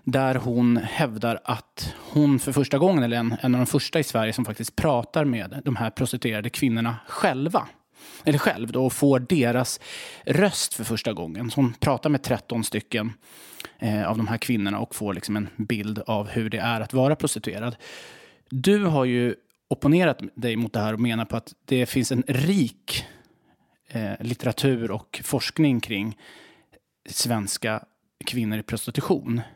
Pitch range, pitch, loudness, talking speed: 115-135 Hz, 120 Hz, -25 LUFS, 165 wpm